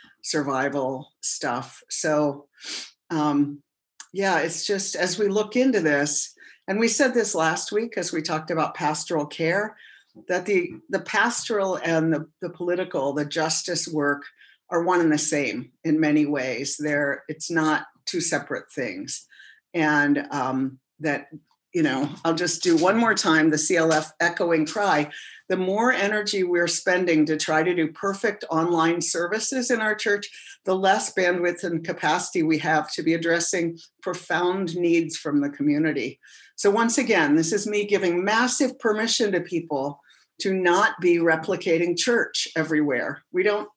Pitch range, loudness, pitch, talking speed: 155-200 Hz, -23 LUFS, 170 Hz, 155 wpm